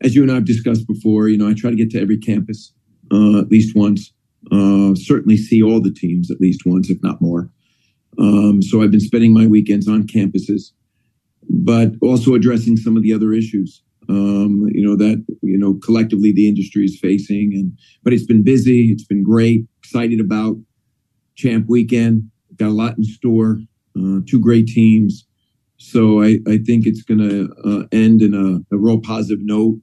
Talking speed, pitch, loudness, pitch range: 190 wpm, 110 Hz, -15 LUFS, 100-115 Hz